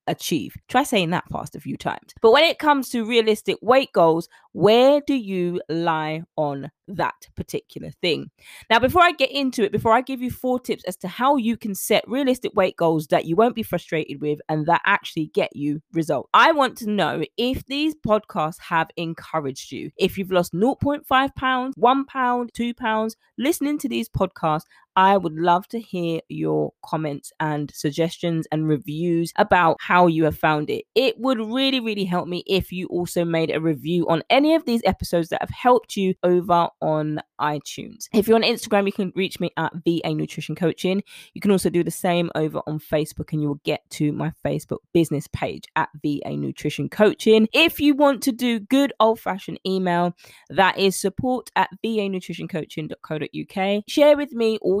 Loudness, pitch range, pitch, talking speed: -21 LUFS, 165-235 Hz, 190 Hz, 190 wpm